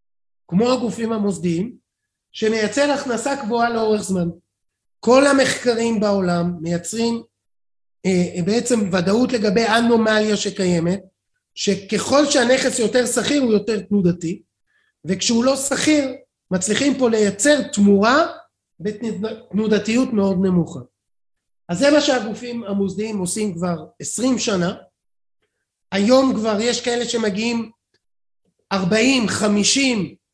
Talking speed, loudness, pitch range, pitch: 100 wpm, -19 LUFS, 190-245 Hz, 220 Hz